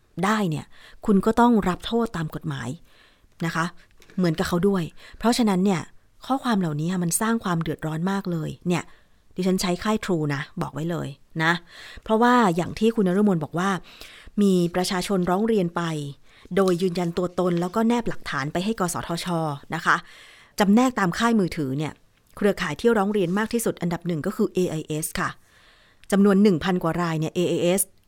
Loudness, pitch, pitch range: -24 LUFS, 180 Hz, 165-200 Hz